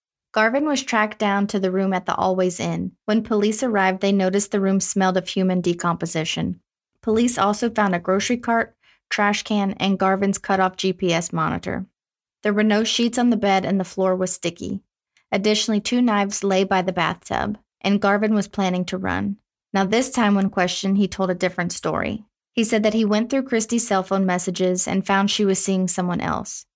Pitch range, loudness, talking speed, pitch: 185-215 Hz, -21 LUFS, 195 wpm, 200 Hz